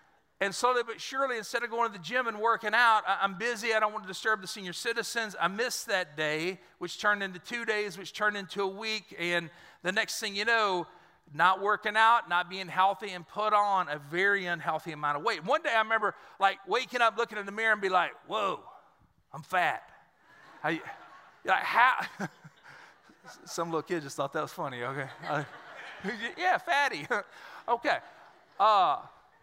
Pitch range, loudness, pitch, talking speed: 180-225 Hz, -29 LUFS, 205 Hz, 190 wpm